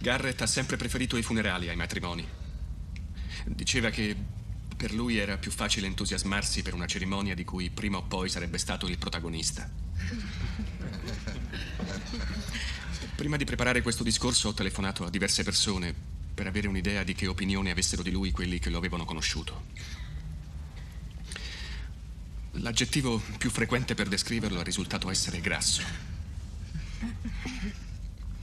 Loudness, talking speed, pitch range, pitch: -31 LUFS, 130 wpm, 85-105 Hz, 95 Hz